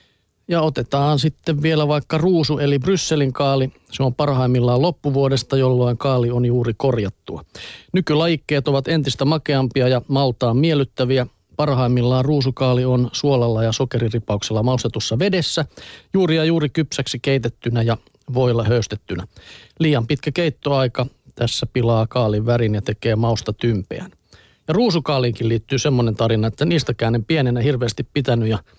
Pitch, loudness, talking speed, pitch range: 130 Hz, -19 LUFS, 135 wpm, 115-150 Hz